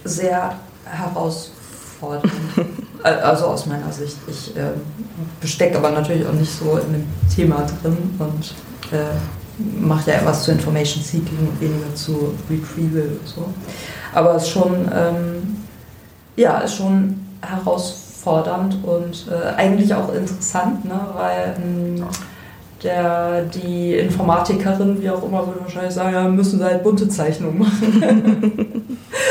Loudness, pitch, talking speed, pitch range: -19 LUFS, 175 Hz, 130 wpm, 155-190 Hz